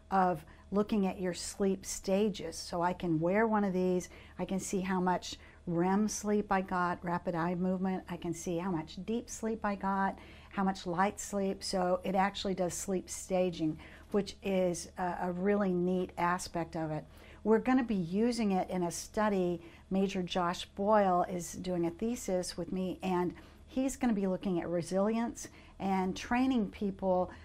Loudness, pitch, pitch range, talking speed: -33 LUFS, 185 Hz, 180-200 Hz, 175 wpm